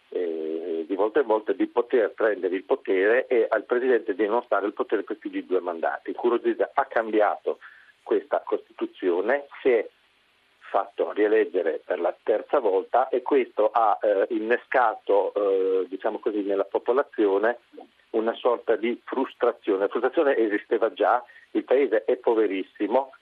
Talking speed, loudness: 145 wpm, -25 LUFS